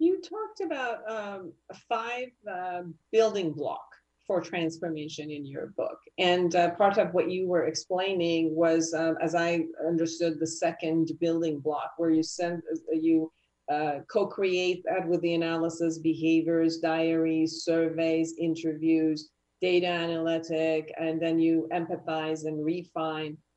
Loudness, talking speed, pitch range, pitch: -28 LUFS, 130 wpm, 160-180 Hz, 165 Hz